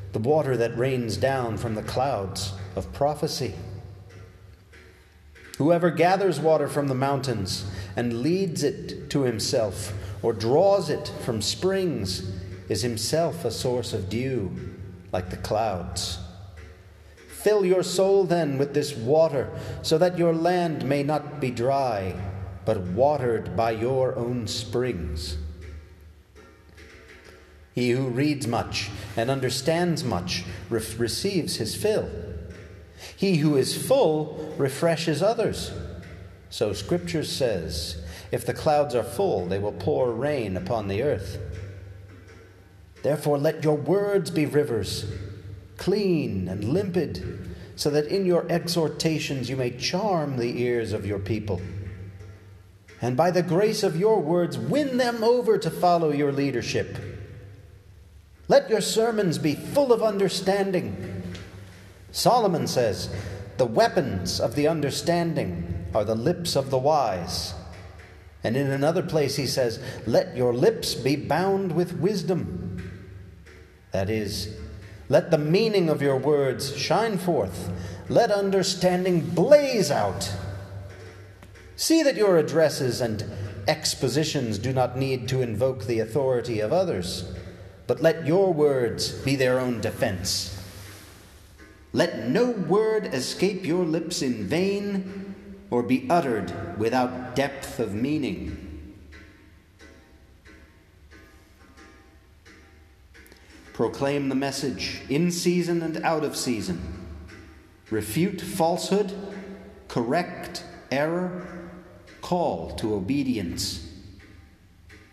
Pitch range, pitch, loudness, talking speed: 95-155 Hz, 115 Hz, -25 LUFS, 115 wpm